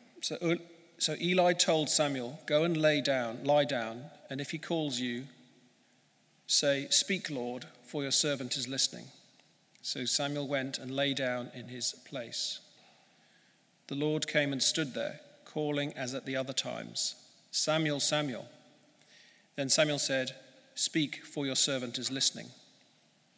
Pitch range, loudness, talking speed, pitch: 130-155 Hz, -31 LUFS, 145 wpm, 145 Hz